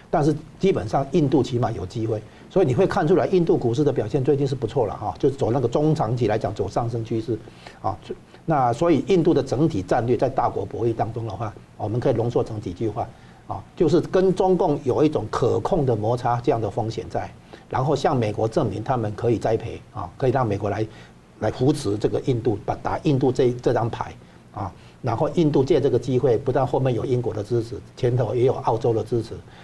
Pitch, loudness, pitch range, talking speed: 120 Hz, -22 LUFS, 110-145 Hz, 325 characters per minute